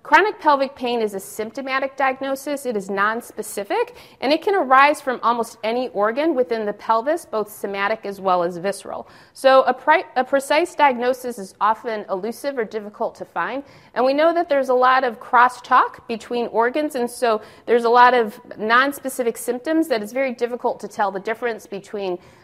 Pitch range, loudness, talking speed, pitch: 215-270 Hz, -20 LUFS, 180 wpm, 245 Hz